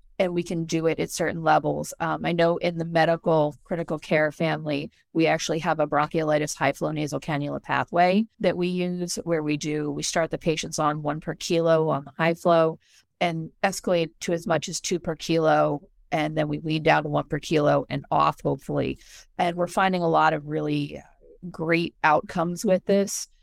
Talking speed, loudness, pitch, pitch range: 195 wpm, -25 LUFS, 165 Hz, 150-175 Hz